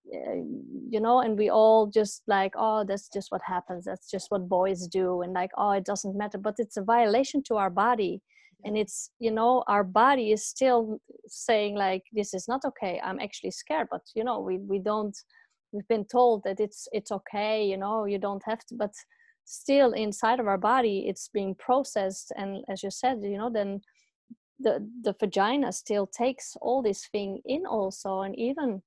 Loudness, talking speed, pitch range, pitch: -28 LUFS, 195 wpm, 200-240 Hz, 215 Hz